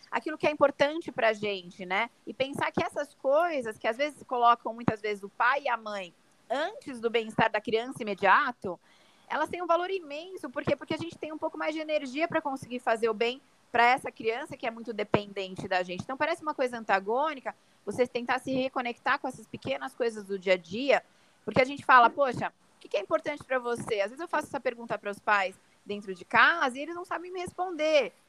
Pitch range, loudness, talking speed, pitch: 220-300 Hz, -29 LUFS, 225 wpm, 255 Hz